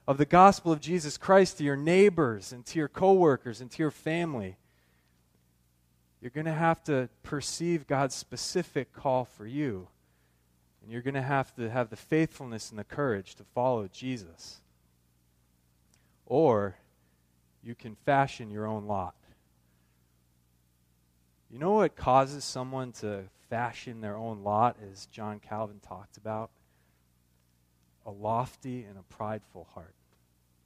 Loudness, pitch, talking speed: -29 LUFS, 110 Hz, 140 wpm